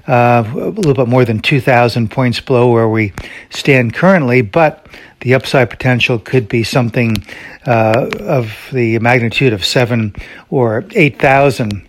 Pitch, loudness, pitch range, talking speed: 120 Hz, -12 LUFS, 115-130 Hz, 150 wpm